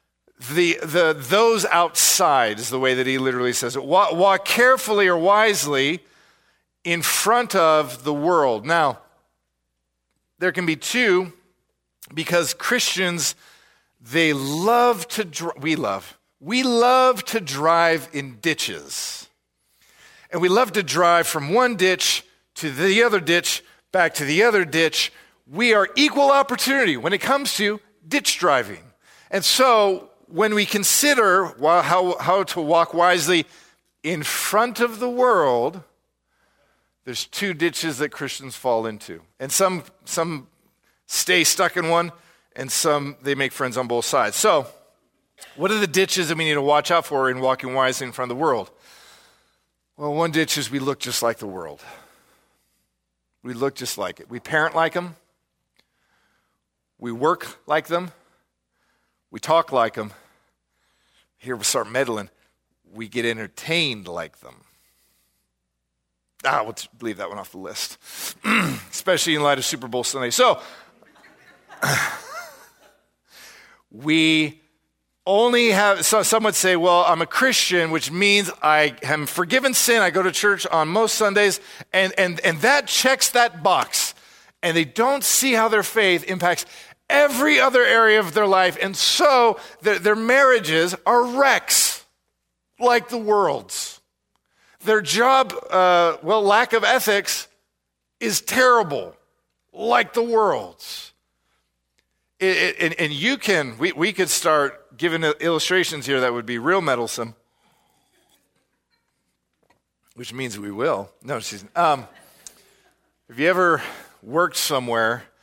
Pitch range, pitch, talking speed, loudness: 135-210 Hz, 170 Hz, 145 wpm, -19 LUFS